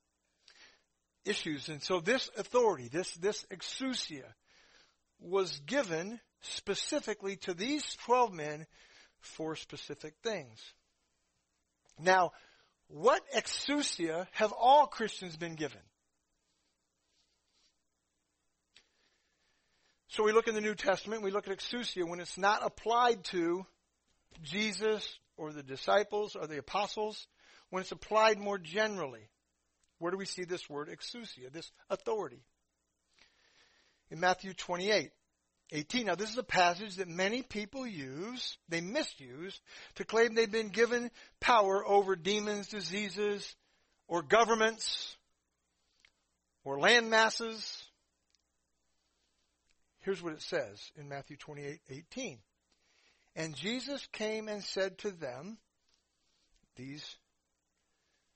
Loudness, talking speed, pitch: -33 LUFS, 110 wpm, 180 Hz